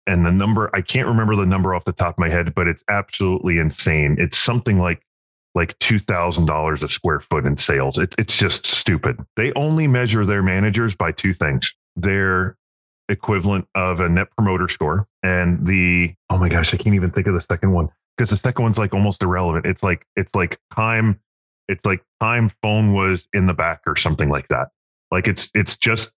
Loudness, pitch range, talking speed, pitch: -19 LUFS, 85-105 Hz, 205 wpm, 95 Hz